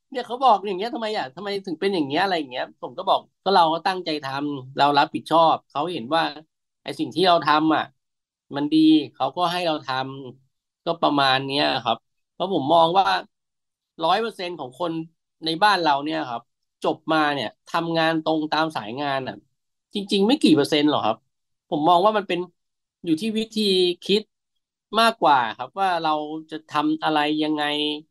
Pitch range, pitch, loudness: 150-195 Hz, 160 Hz, -22 LUFS